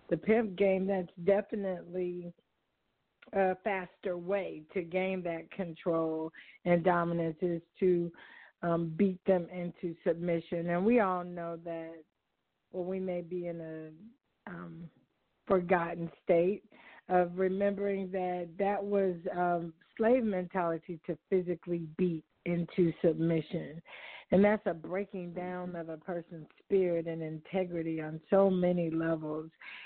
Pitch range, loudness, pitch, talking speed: 170-190 Hz, -33 LUFS, 180 Hz, 125 wpm